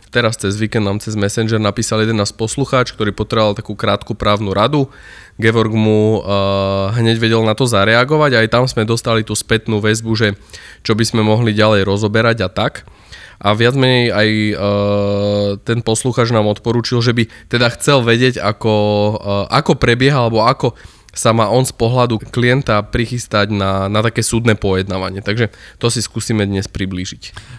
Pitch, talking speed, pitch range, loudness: 110 Hz, 170 wpm, 100-115 Hz, -15 LUFS